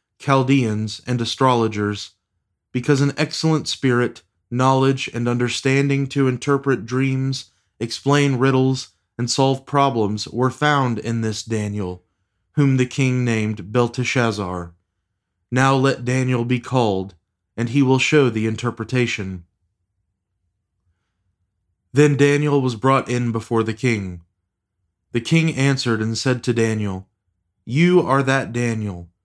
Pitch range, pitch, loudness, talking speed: 100-135 Hz, 120 Hz, -20 LUFS, 120 wpm